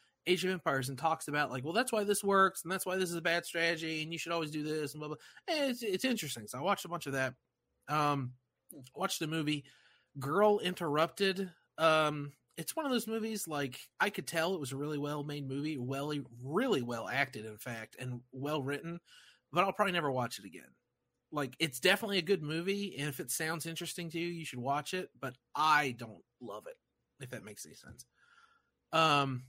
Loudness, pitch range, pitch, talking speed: -34 LUFS, 140-185 Hz, 160 Hz, 220 wpm